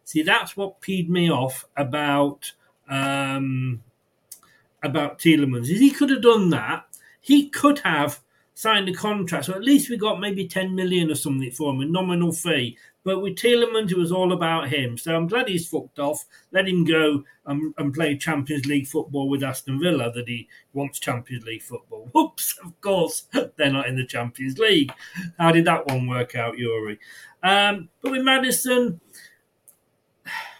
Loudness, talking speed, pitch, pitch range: -22 LUFS, 175 wpm, 160 Hz, 140-195 Hz